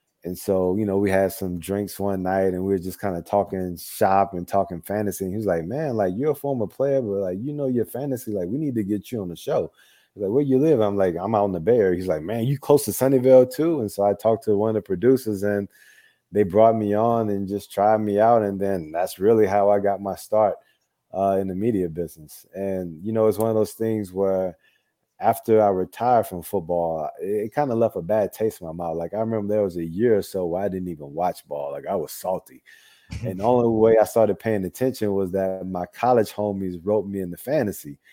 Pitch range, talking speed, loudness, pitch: 95-110 Hz, 255 wpm, -23 LUFS, 100 Hz